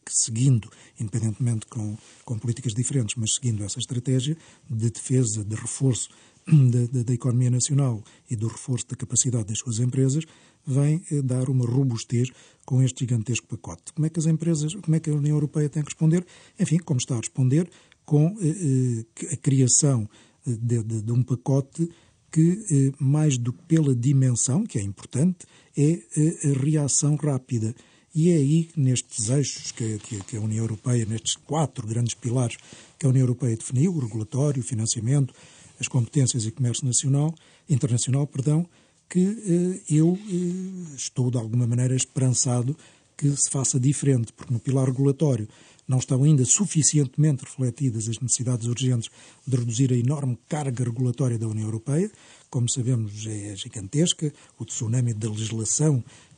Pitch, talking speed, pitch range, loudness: 130 Hz, 155 wpm, 120-150 Hz, -24 LUFS